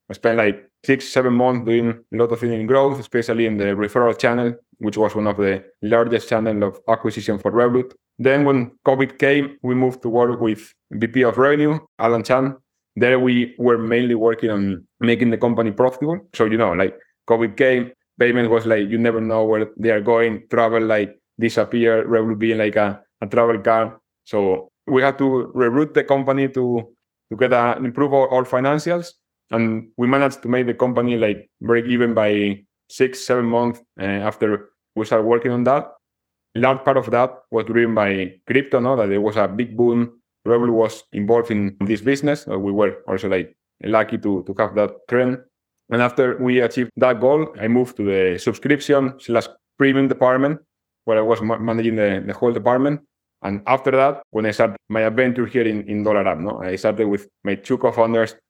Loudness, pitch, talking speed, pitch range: -19 LUFS, 115 Hz, 195 wpm, 110-125 Hz